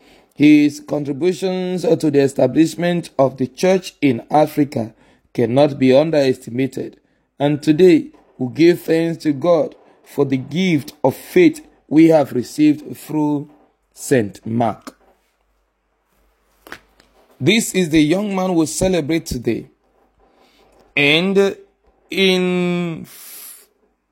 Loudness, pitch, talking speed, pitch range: -17 LUFS, 160 Hz, 100 wpm, 140-185 Hz